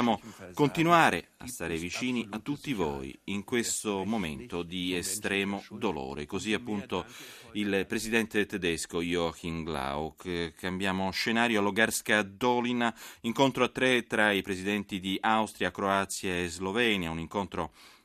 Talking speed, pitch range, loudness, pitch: 125 wpm, 90-115 Hz, -30 LUFS, 100 Hz